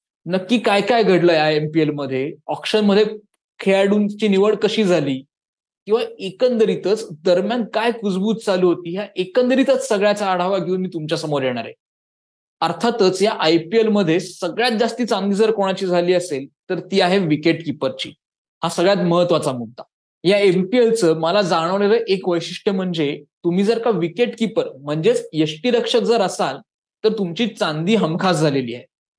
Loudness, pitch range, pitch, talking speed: -19 LUFS, 165-220 Hz, 190 Hz, 155 wpm